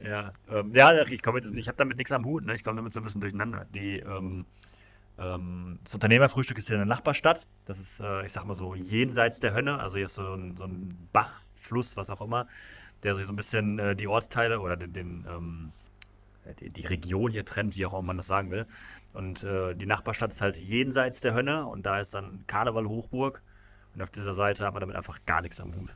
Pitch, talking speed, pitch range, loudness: 100 Hz, 235 wpm, 95-115 Hz, -29 LUFS